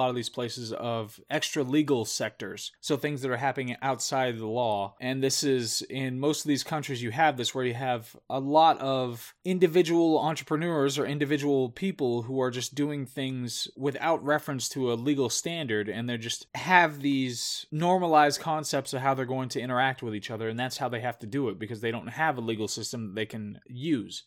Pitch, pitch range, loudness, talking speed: 130 Hz, 120-150 Hz, -28 LUFS, 210 wpm